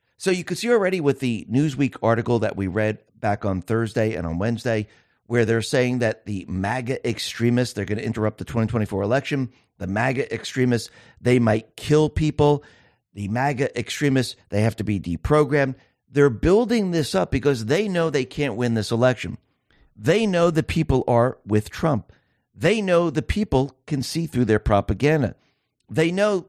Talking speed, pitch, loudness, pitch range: 175 wpm, 125 Hz, -22 LUFS, 110-145 Hz